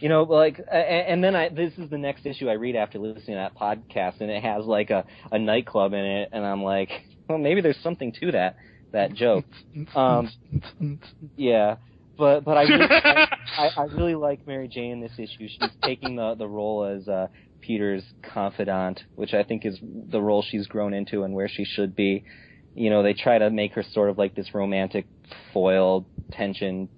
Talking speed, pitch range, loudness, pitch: 200 wpm, 100-140 Hz, -24 LUFS, 110 Hz